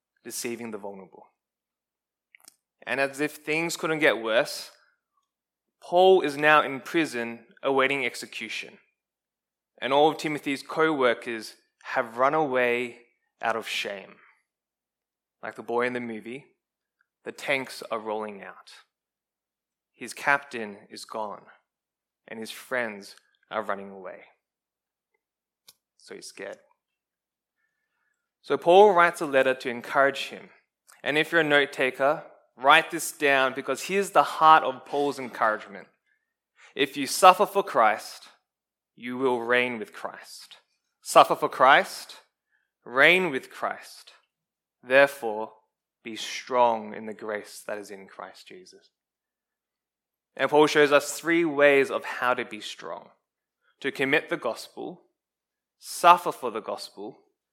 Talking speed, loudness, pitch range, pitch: 130 wpm, -24 LUFS, 120-155 Hz, 135 Hz